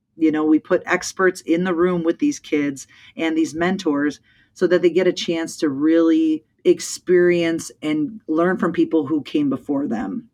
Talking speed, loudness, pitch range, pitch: 180 wpm, -20 LUFS, 160-185 Hz, 175 Hz